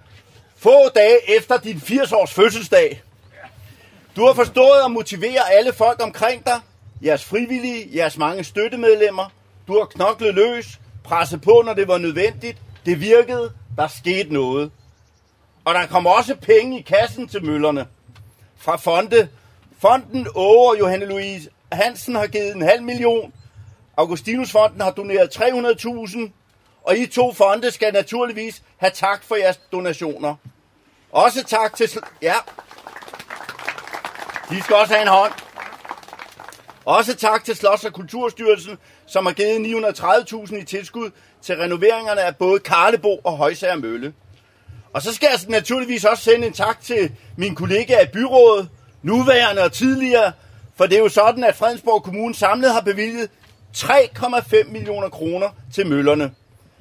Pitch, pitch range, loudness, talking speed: 205 Hz, 150-230 Hz, -17 LUFS, 140 wpm